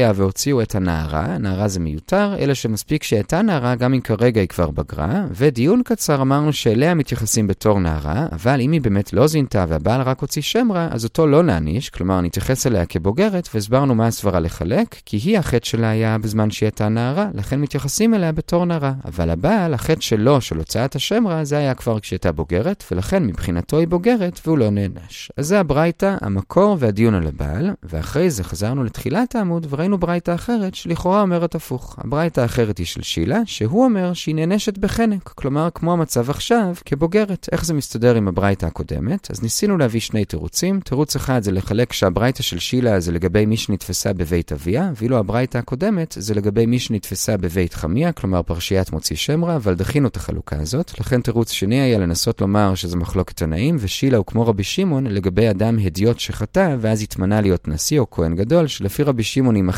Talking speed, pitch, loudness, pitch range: 165 wpm, 120 Hz, -19 LUFS, 100-160 Hz